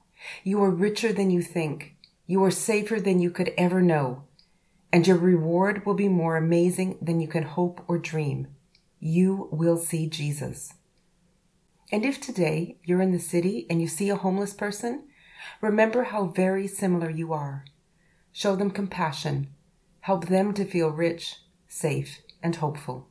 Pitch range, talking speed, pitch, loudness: 165-190 Hz, 160 wpm, 175 Hz, -25 LUFS